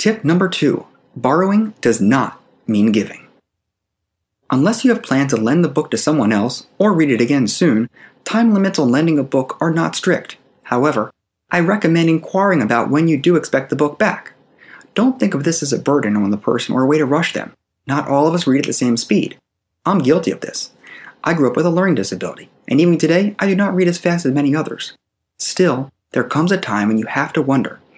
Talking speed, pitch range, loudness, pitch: 220 wpm, 125-180 Hz, -16 LUFS, 155 Hz